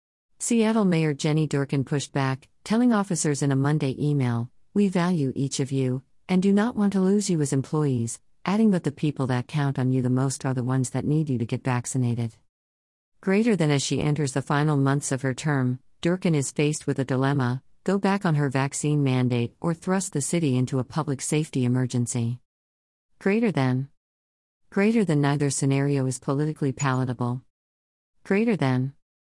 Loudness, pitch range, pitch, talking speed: -25 LUFS, 125-155 Hz, 140 Hz, 180 wpm